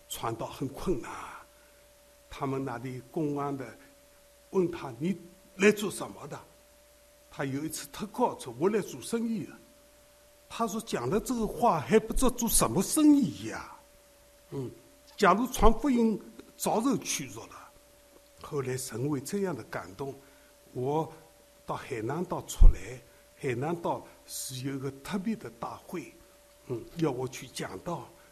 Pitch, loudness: 210 Hz, -31 LUFS